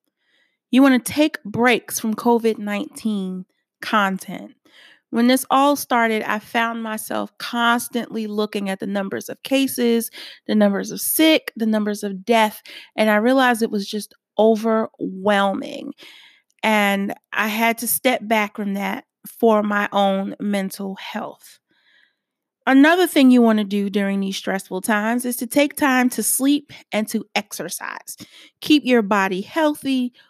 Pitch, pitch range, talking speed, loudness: 225 Hz, 205-265 Hz, 145 wpm, -19 LUFS